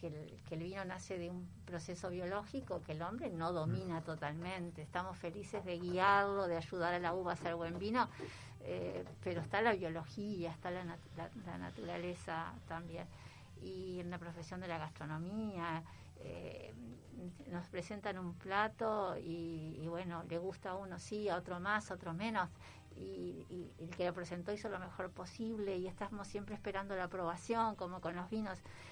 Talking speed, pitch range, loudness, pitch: 180 wpm, 165-195 Hz, -42 LUFS, 180 Hz